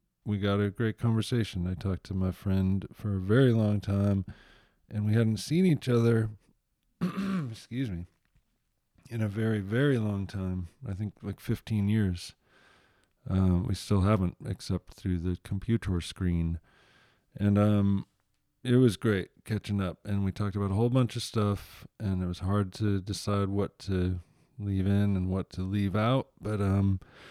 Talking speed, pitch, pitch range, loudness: 165 wpm, 100 Hz, 95-110 Hz, -30 LUFS